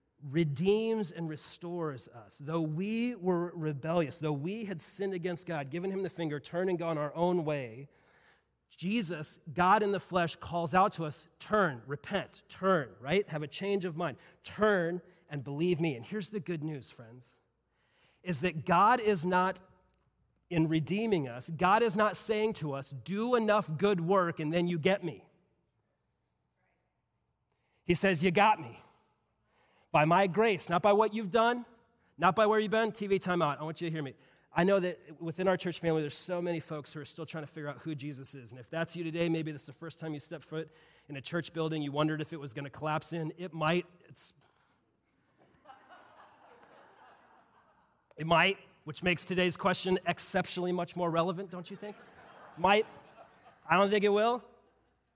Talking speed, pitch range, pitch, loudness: 185 wpm, 155-195 Hz, 170 Hz, -31 LUFS